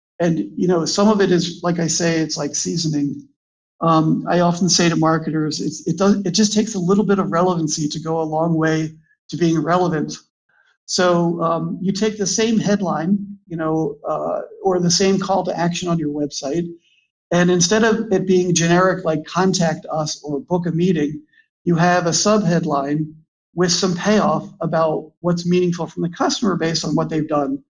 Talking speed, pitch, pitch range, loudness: 195 wpm, 170 Hz, 160-190 Hz, -18 LUFS